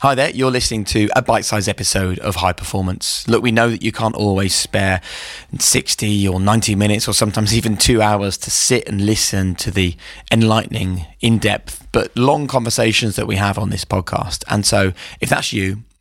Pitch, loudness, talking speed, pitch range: 105 Hz, -16 LUFS, 195 wpm, 95-115 Hz